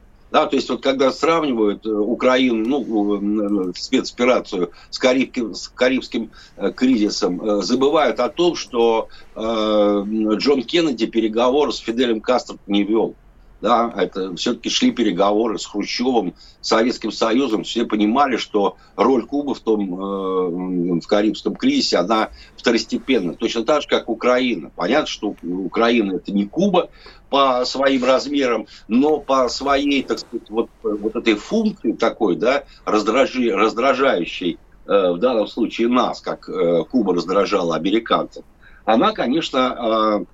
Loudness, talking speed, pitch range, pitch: -19 LUFS, 130 wpm, 105-135 Hz, 115 Hz